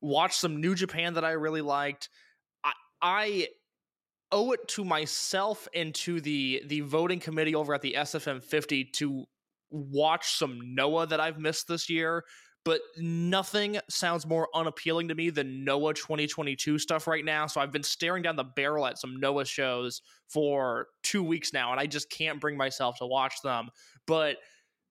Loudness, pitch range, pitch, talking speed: -30 LUFS, 140-165 Hz, 155 Hz, 170 wpm